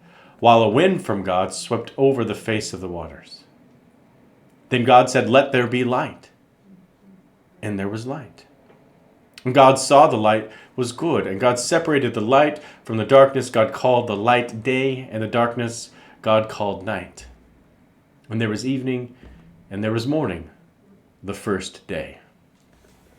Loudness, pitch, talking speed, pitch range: -19 LUFS, 115 Hz, 155 wpm, 105-130 Hz